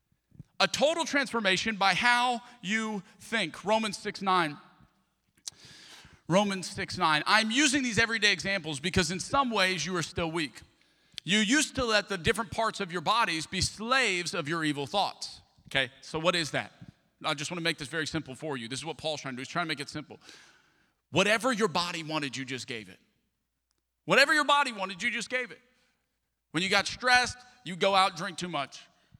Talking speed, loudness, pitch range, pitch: 200 wpm, -28 LUFS, 155-225 Hz, 185 Hz